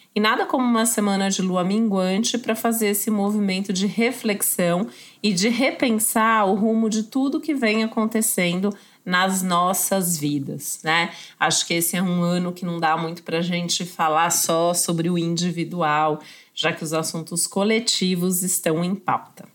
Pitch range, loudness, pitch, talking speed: 175-220 Hz, -21 LUFS, 190 Hz, 165 wpm